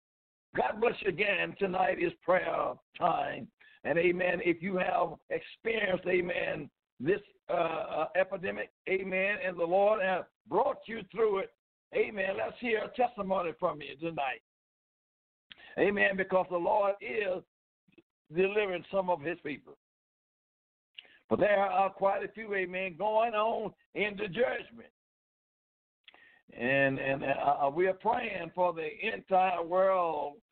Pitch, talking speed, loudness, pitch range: 190 Hz, 130 wpm, -31 LUFS, 180-215 Hz